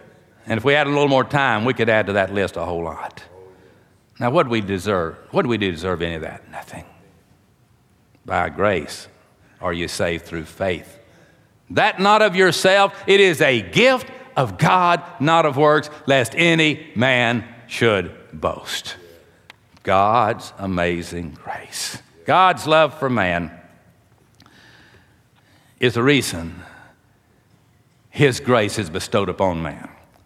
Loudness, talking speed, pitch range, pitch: -18 LUFS, 145 wpm, 95-150 Hz, 120 Hz